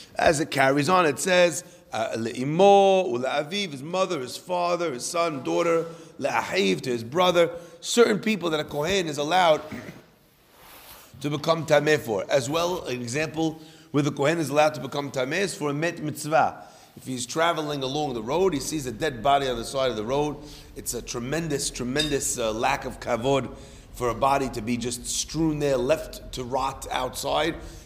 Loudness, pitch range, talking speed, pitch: -25 LUFS, 135-170 Hz, 170 wpm, 150 Hz